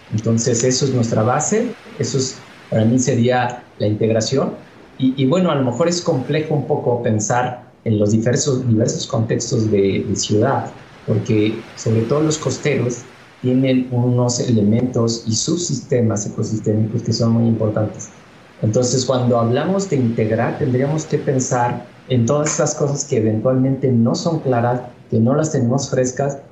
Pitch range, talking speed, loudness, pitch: 115-140 Hz, 155 wpm, -18 LUFS, 125 Hz